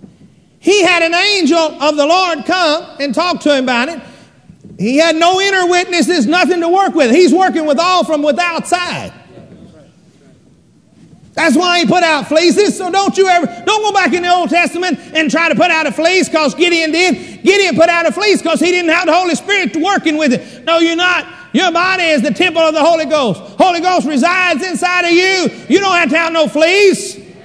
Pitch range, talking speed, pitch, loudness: 305-360 Hz, 210 wpm, 335 Hz, -11 LUFS